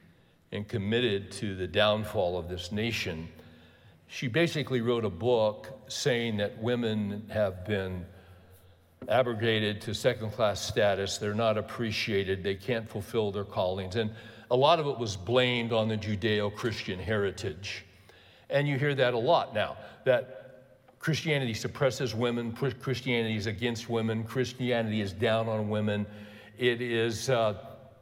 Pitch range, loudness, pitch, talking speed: 100-120 Hz, -30 LUFS, 110 Hz, 135 wpm